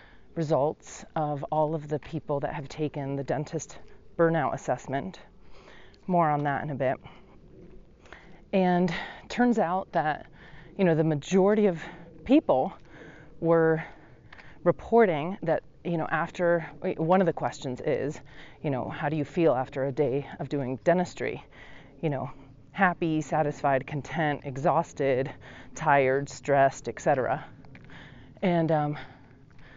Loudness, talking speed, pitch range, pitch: -27 LUFS, 130 wpm, 140-170 Hz, 155 Hz